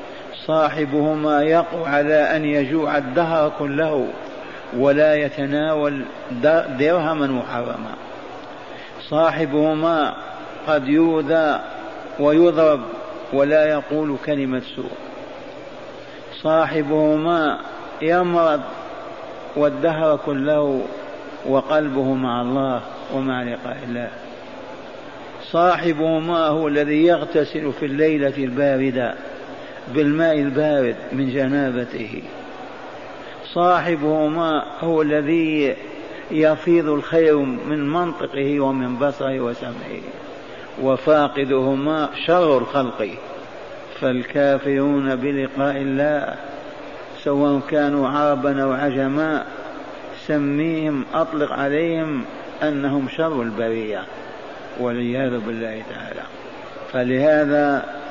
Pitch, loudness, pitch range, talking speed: 150 Hz, -20 LUFS, 135-155 Hz, 75 wpm